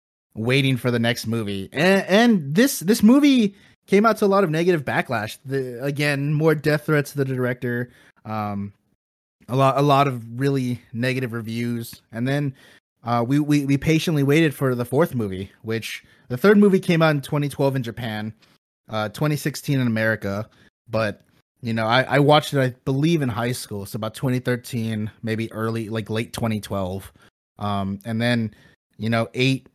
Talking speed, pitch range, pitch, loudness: 185 wpm, 110-145 Hz, 125 Hz, -21 LUFS